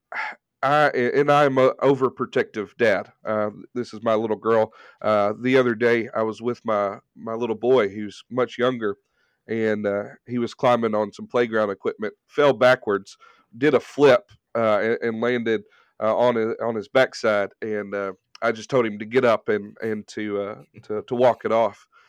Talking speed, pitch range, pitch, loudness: 180 wpm, 105-125 Hz, 110 Hz, -22 LUFS